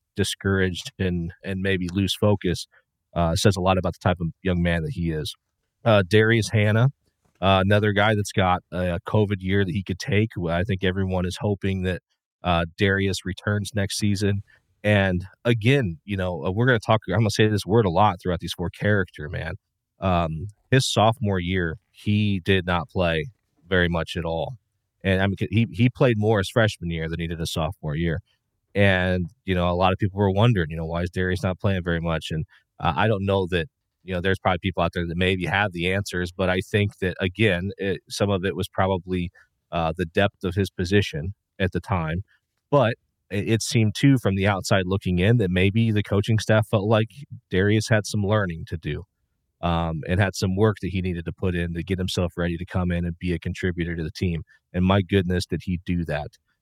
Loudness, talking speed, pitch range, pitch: -23 LUFS, 215 wpm, 90-105 Hz, 95 Hz